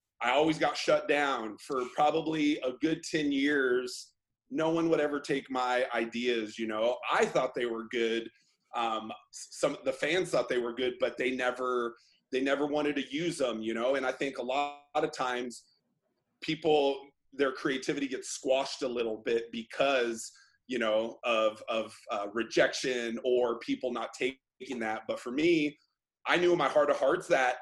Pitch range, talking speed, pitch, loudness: 115-150 Hz, 180 wpm, 130 Hz, -31 LUFS